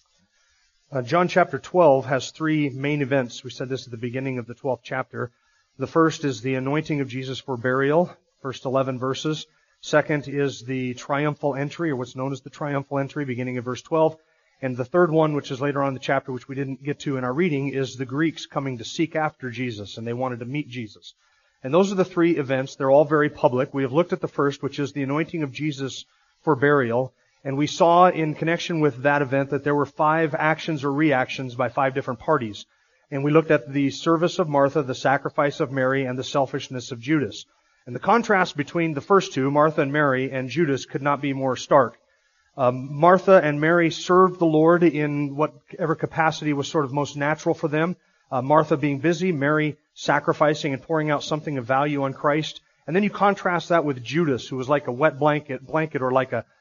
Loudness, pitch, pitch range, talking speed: -23 LUFS, 145 Hz, 130-160 Hz, 215 wpm